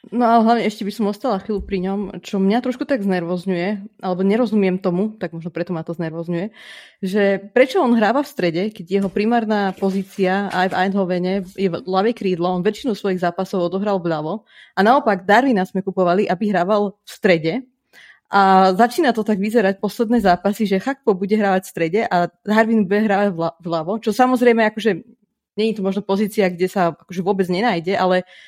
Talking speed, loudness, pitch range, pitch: 185 wpm, -19 LUFS, 185-220 Hz, 200 Hz